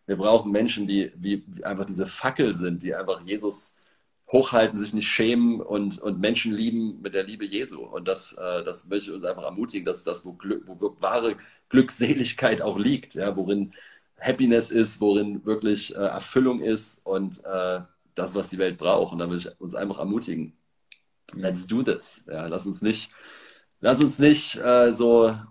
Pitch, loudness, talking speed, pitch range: 105 Hz, -25 LUFS, 185 wpm, 100-120 Hz